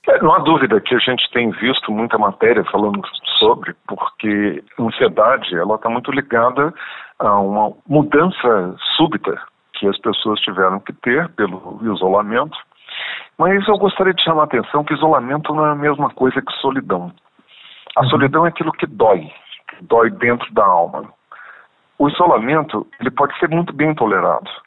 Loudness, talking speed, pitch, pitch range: -16 LUFS, 160 wpm, 140 Hz, 105-155 Hz